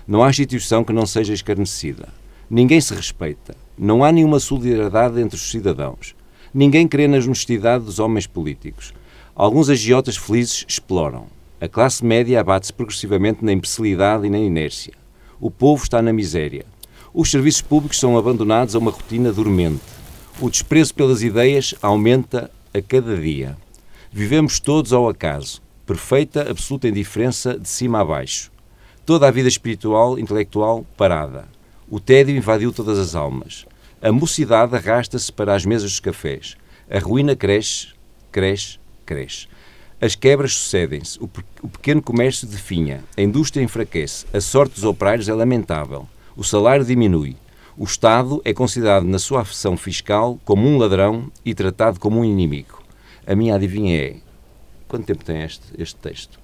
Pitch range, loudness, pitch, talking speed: 100-125 Hz, -18 LUFS, 110 Hz, 150 wpm